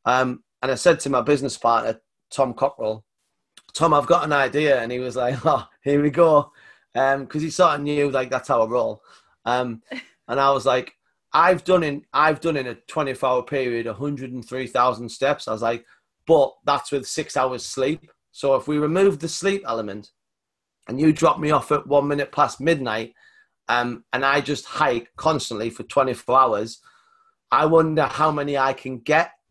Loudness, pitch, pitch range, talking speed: -21 LUFS, 140 Hz, 125-155 Hz, 200 wpm